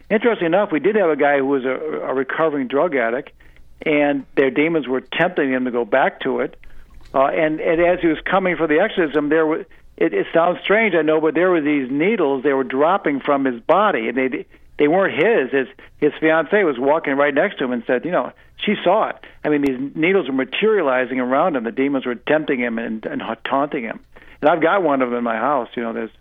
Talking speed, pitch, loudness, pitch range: 230 wpm, 145 Hz, -19 LUFS, 130-160 Hz